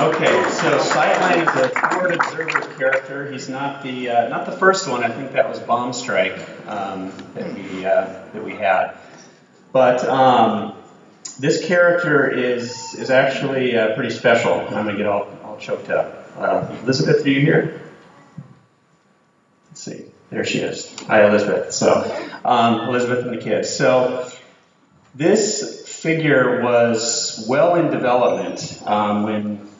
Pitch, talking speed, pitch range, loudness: 125 Hz, 145 wpm, 115-140 Hz, -18 LUFS